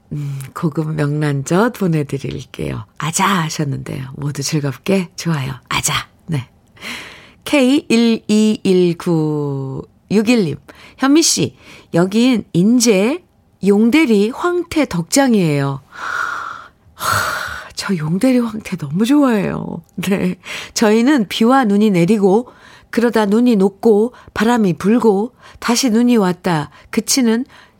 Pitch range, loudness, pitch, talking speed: 160-235 Hz, -16 LUFS, 200 Hz, 205 characters per minute